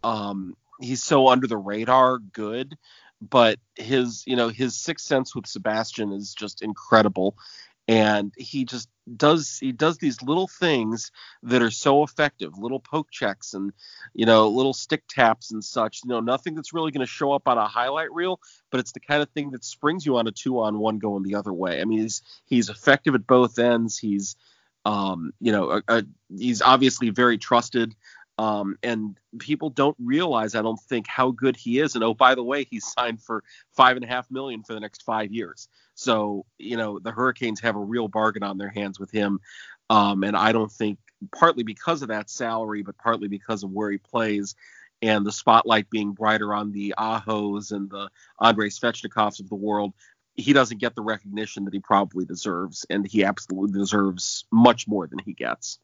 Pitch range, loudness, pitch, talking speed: 105-130 Hz, -23 LUFS, 115 Hz, 195 wpm